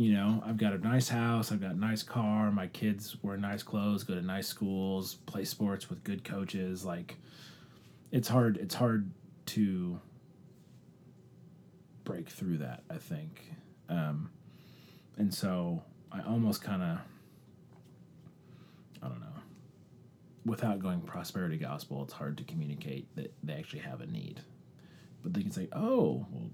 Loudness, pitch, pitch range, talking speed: -35 LUFS, 105 Hz, 95-115 Hz, 150 wpm